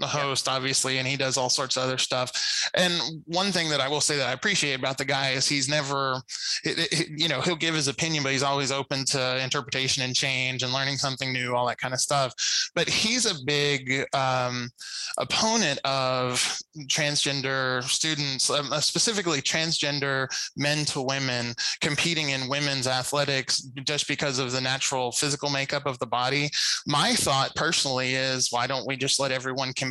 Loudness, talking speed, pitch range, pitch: -25 LUFS, 185 wpm, 130-145 Hz, 135 Hz